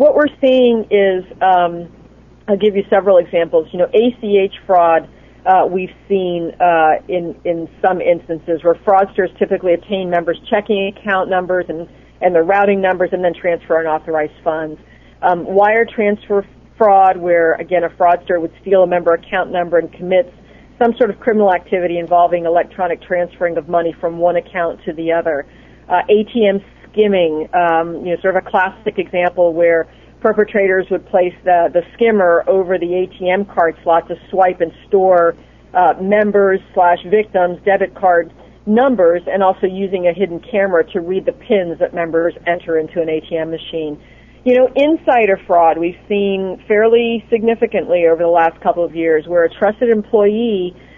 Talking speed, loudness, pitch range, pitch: 165 wpm, -15 LUFS, 170-200 Hz, 180 Hz